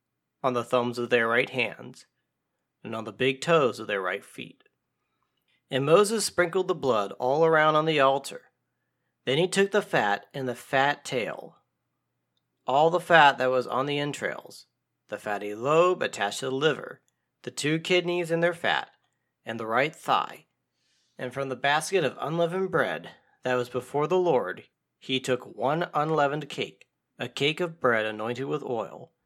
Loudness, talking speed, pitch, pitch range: -26 LUFS, 170 wpm, 135 Hz, 120-165 Hz